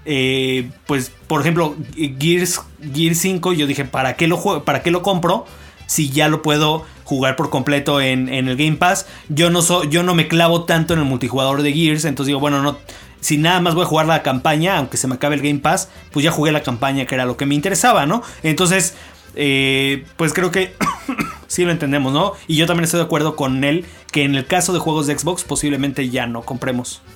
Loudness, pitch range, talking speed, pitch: -17 LUFS, 140-170 Hz, 230 wpm, 155 Hz